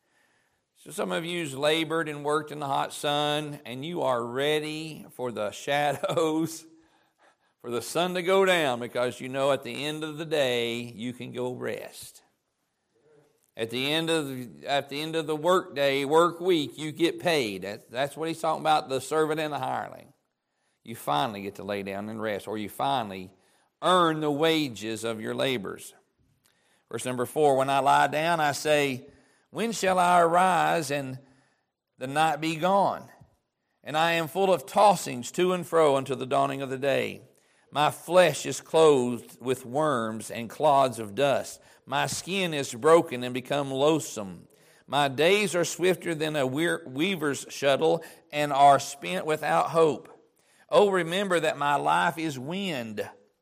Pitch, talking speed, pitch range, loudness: 150 Hz, 170 wpm, 130-165 Hz, -26 LUFS